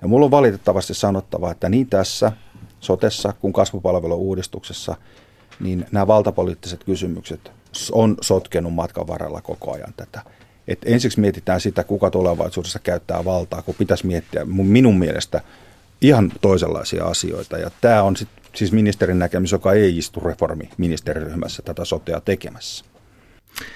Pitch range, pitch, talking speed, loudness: 90-105 Hz, 95 Hz, 130 wpm, -19 LUFS